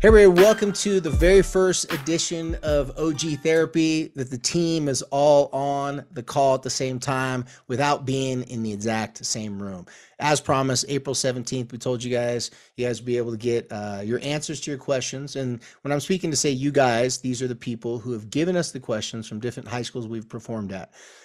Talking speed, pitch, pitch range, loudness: 215 wpm, 130 Hz, 120-150 Hz, -23 LUFS